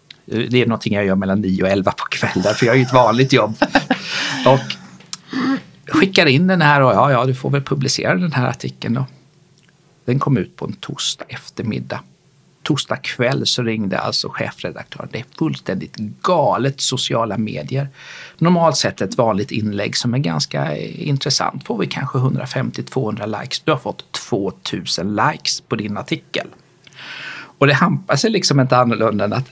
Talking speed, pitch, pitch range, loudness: 170 wpm, 130 Hz, 115-145 Hz, -18 LUFS